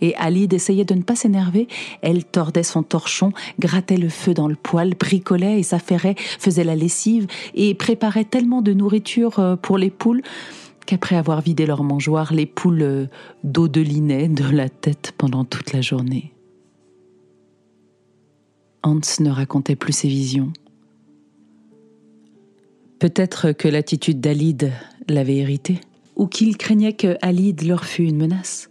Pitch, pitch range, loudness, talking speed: 165 Hz, 140-190 Hz, -19 LUFS, 140 wpm